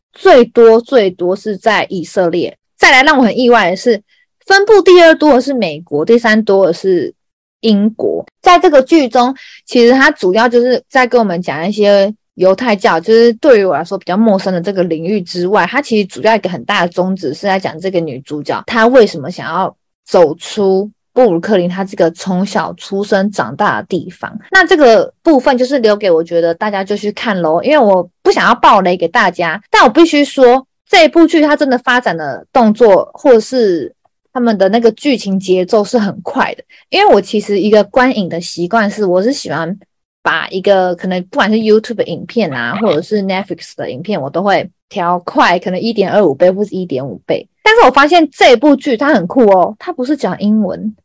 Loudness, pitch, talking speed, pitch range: -11 LUFS, 215 Hz, 310 characters per minute, 185-255 Hz